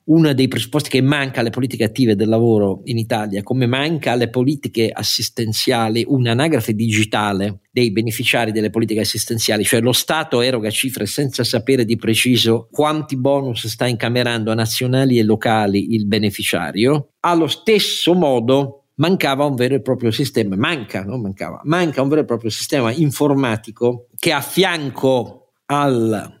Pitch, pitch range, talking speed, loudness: 120 Hz, 110-140 Hz, 150 wpm, -17 LUFS